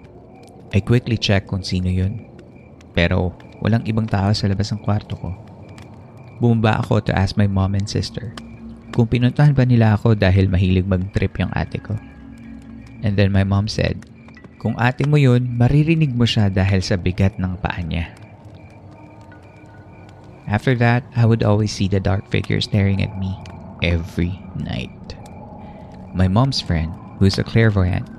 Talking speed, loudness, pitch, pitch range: 155 wpm, -19 LUFS, 105 Hz, 95-115 Hz